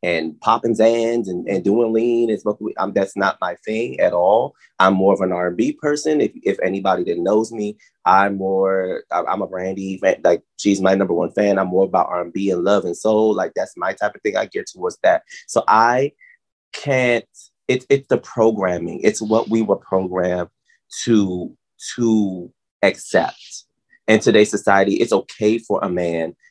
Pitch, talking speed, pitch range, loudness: 105 Hz, 185 wpm, 95-115 Hz, -19 LUFS